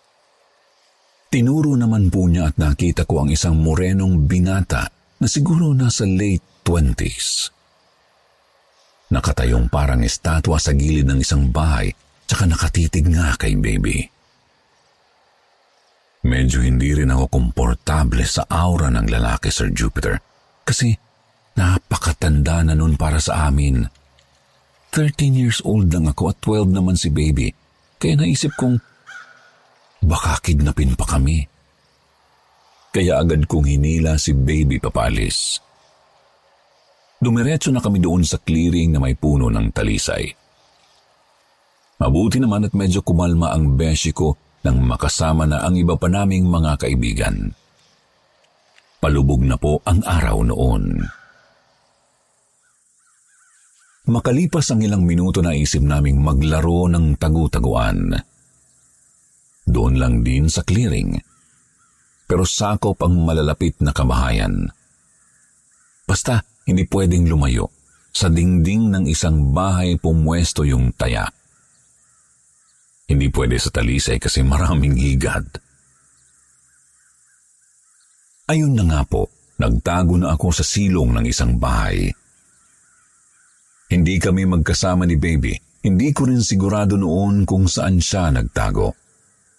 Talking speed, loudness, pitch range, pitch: 115 wpm, -18 LUFS, 75-95 Hz, 80 Hz